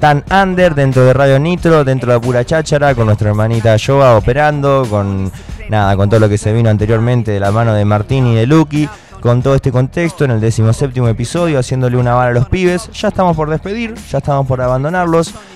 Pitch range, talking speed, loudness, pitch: 115-150 Hz, 210 wpm, -12 LUFS, 130 Hz